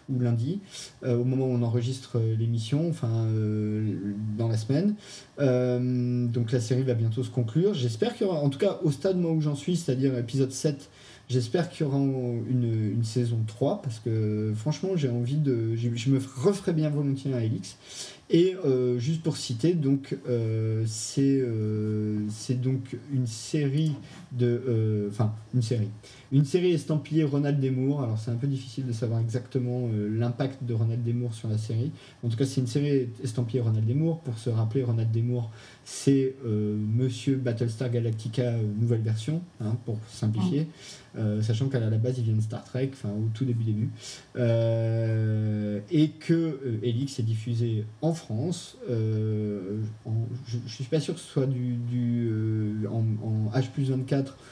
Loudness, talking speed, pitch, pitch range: -28 LUFS, 175 wpm, 125 Hz, 115-135 Hz